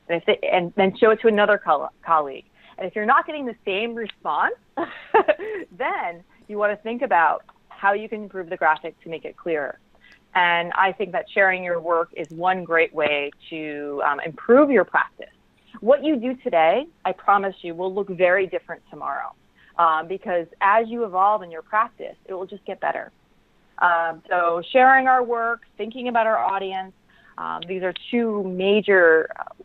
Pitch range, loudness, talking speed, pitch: 170-230 Hz, -21 LUFS, 180 wpm, 195 Hz